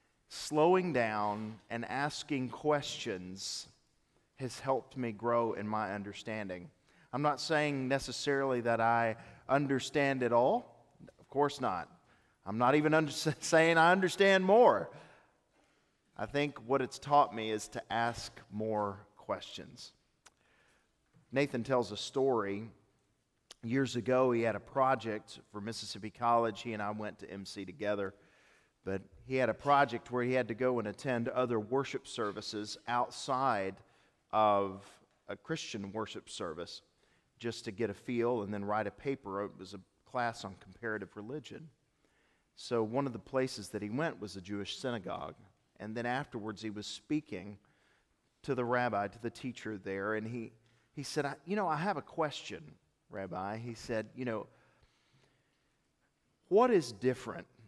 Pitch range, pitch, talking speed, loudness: 105-135 Hz, 120 Hz, 150 wpm, -34 LUFS